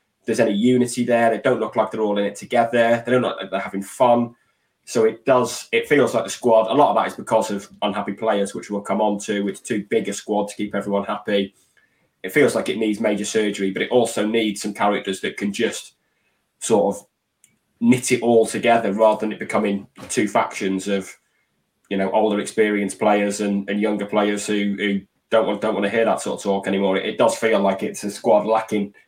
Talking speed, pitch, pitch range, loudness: 230 wpm, 105 Hz, 100-115 Hz, -20 LUFS